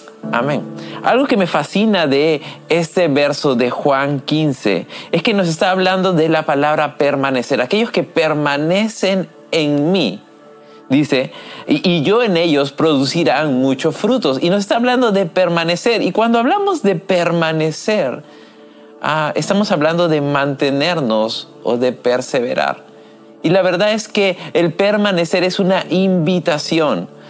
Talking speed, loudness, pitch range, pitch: 140 wpm, -15 LUFS, 145-190 Hz, 170 Hz